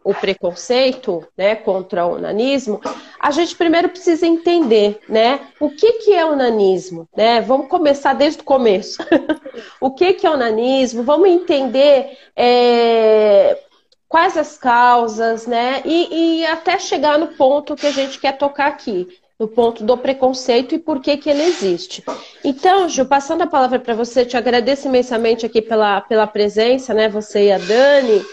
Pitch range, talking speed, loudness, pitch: 225-310 Hz, 165 wpm, -15 LUFS, 265 Hz